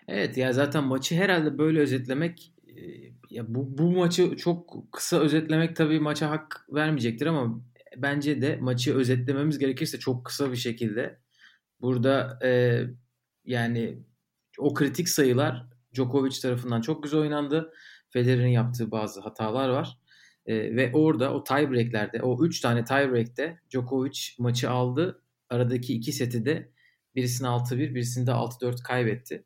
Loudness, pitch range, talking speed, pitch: -27 LUFS, 125-150 Hz, 135 wpm, 130 Hz